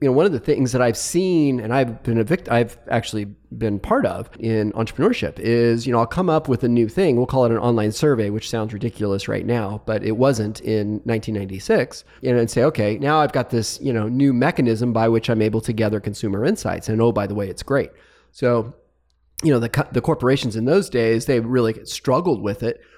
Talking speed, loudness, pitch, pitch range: 230 wpm, -20 LUFS, 115 Hz, 110-125 Hz